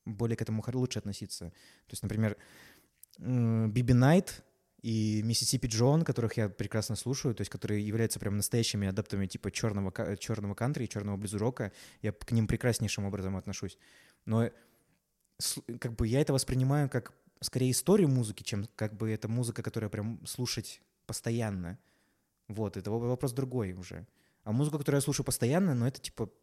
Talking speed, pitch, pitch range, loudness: 160 wpm, 115 Hz, 105-125 Hz, -32 LUFS